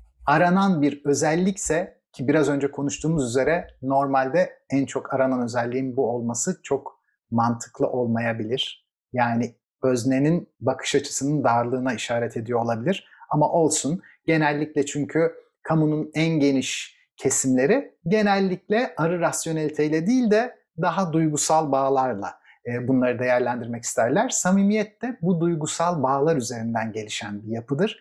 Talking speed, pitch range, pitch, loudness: 115 wpm, 125-165 Hz, 140 Hz, -23 LUFS